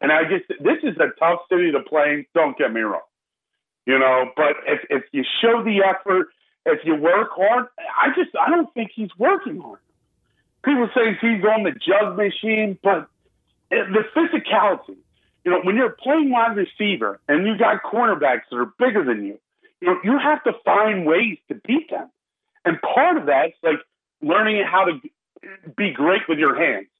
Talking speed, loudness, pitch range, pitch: 190 wpm, -19 LUFS, 185-290 Hz, 220 Hz